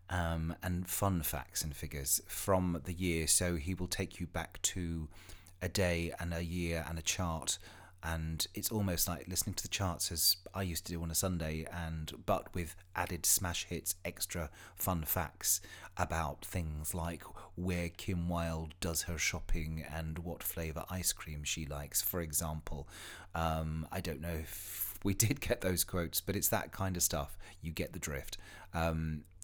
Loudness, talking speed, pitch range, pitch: -36 LUFS, 180 wpm, 80-90 Hz, 85 Hz